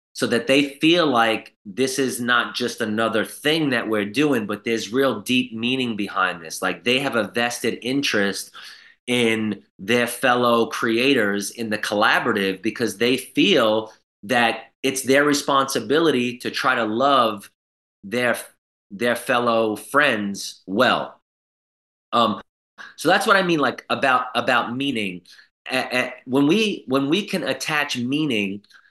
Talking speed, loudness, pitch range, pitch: 145 wpm, -21 LUFS, 110-135 Hz, 120 Hz